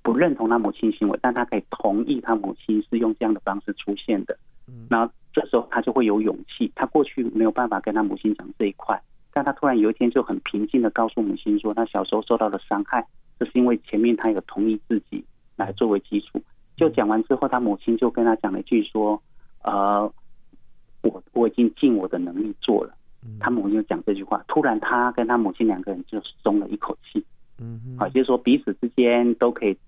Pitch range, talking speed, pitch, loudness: 110-125 Hz, 325 characters per minute, 115 Hz, -23 LUFS